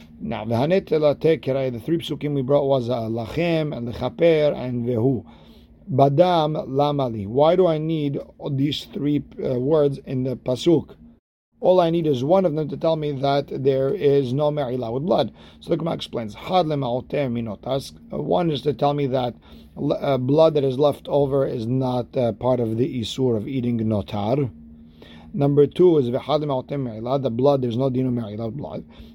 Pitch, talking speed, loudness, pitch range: 135 Hz, 165 wpm, -22 LUFS, 120-145 Hz